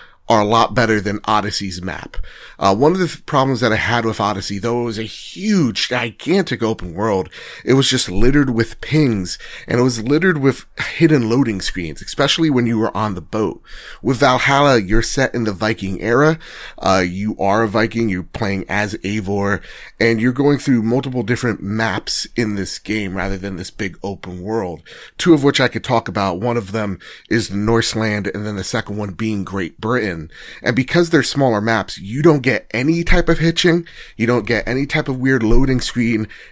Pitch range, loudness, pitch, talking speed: 105-130 Hz, -17 LUFS, 115 Hz, 200 wpm